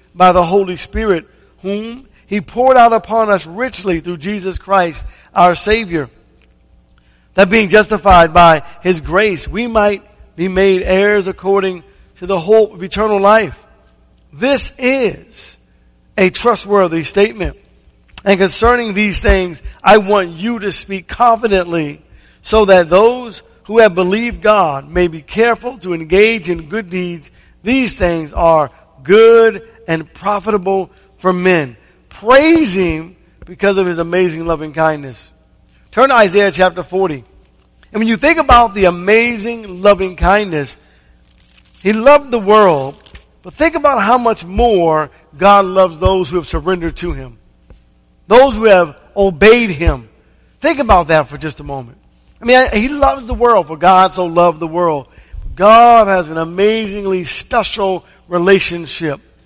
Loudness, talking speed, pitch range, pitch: -12 LUFS, 145 wpm, 165-215 Hz, 190 Hz